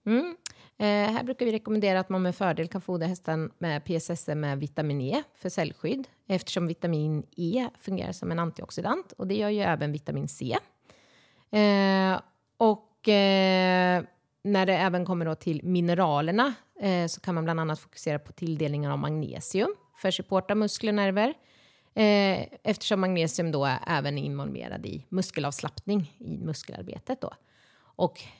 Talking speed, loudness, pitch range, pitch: 160 wpm, -28 LUFS, 160-205 Hz, 185 Hz